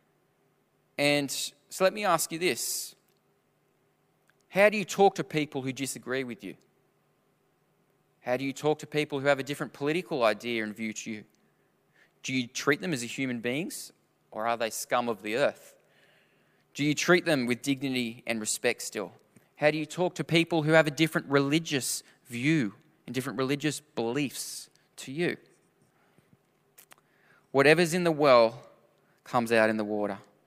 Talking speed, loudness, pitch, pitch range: 165 wpm, -28 LUFS, 140 Hz, 120-155 Hz